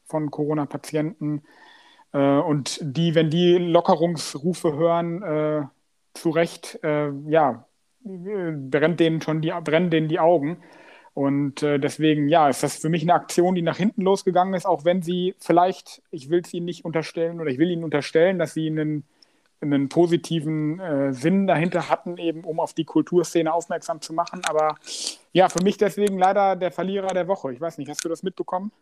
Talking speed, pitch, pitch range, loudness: 175 wpm, 165 Hz, 155-175 Hz, -23 LUFS